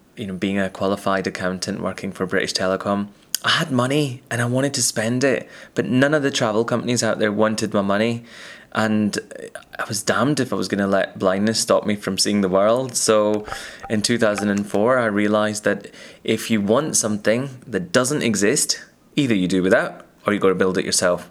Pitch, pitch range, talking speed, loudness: 105 Hz, 100-115 Hz, 205 wpm, -20 LUFS